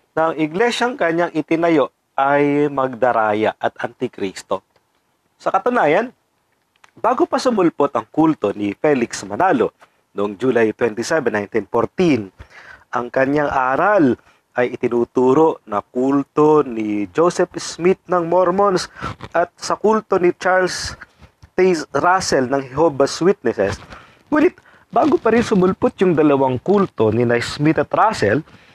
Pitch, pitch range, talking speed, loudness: 150 Hz, 125-180 Hz, 115 wpm, -18 LUFS